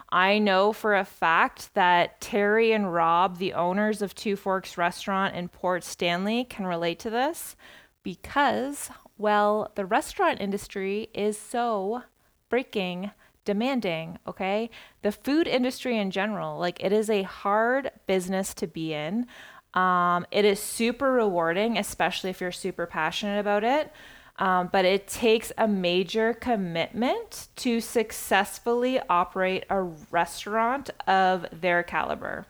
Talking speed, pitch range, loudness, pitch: 135 wpm, 185-225 Hz, -26 LUFS, 205 Hz